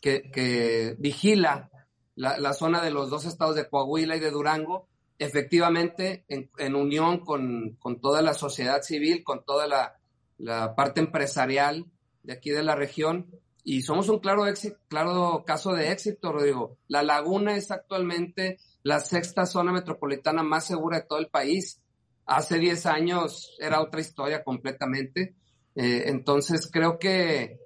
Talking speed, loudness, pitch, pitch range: 155 wpm, -27 LUFS, 155 Hz, 140-175 Hz